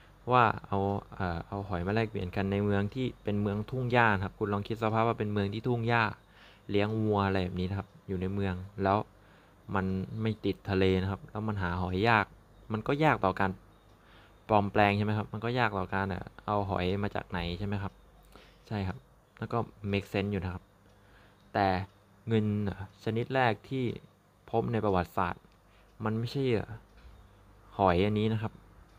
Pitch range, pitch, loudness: 95-110 Hz, 100 Hz, -31 LUFS